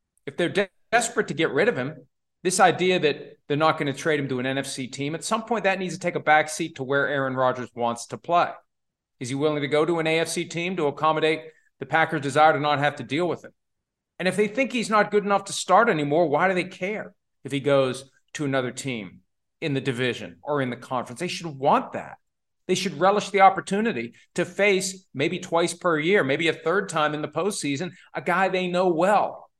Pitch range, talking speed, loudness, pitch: 140-185 Hz, 235 wpm, -24 LUFS, 160 Hz